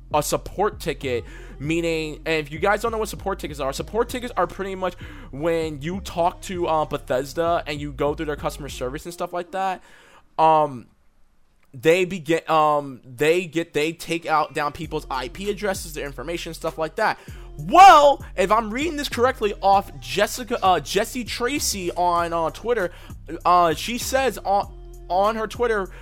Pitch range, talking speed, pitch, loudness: 155-200 Hz, 175 wpm, 170 Hz, -22 LUFS